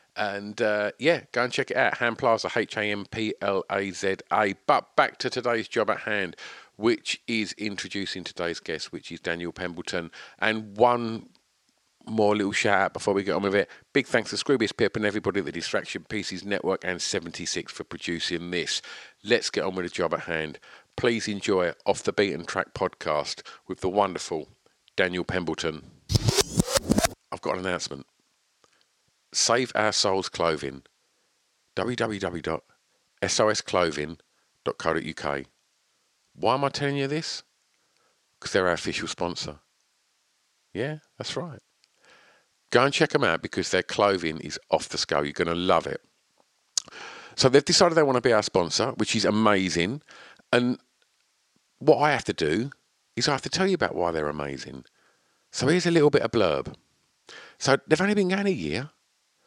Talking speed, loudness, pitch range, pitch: 165 wpm, -26 LUFS, 85-120 Hz, 100 Hz